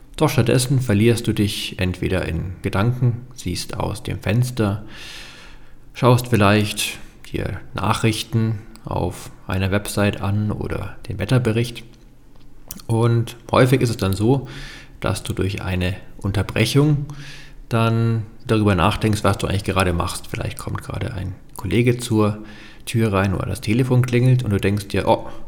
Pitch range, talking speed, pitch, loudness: 100-120 Hz, 140 wpm, 110 Hz, -20 LUFS